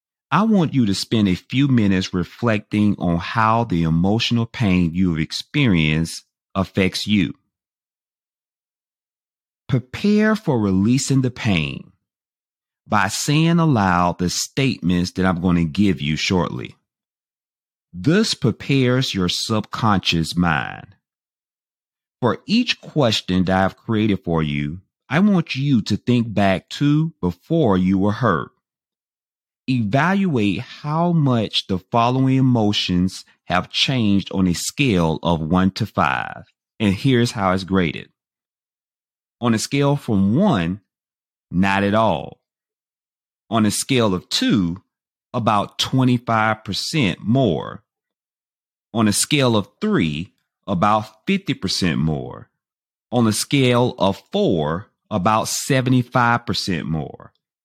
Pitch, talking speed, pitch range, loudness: 105 Hz, 115 wpm, 90-130 Hz, -19 LUFS